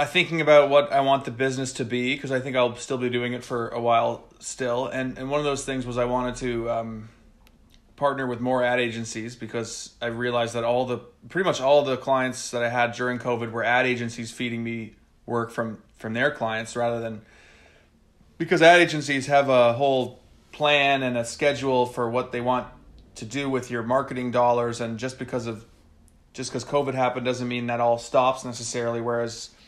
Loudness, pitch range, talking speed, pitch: -24 LUFS, 115-130 Hz, 200 wpm, 120 Hz